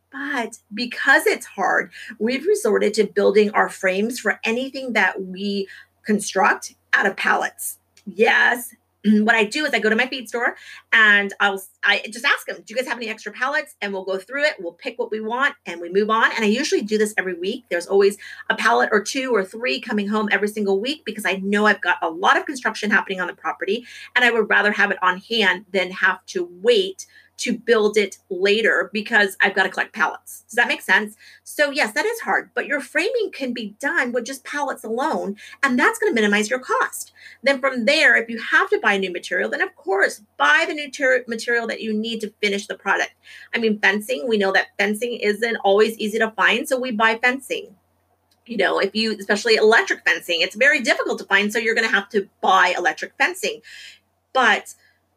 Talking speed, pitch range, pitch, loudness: 220 wpm, 200-265 Hz, 220 Hz, -20 LUFS